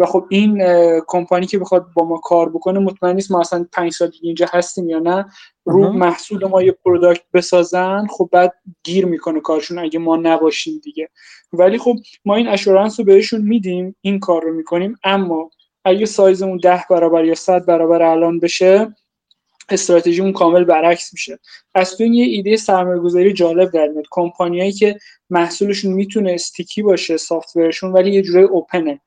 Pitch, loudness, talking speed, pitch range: 180 Hz, -15 LUFS, 170 wpm, 170-195 Hz